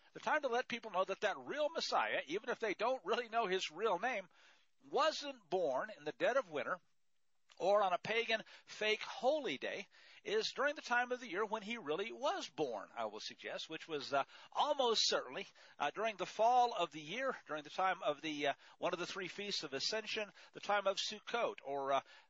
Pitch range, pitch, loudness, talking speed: 175-245 Hz, 215 Hz, -38 LUFS, 215 wpm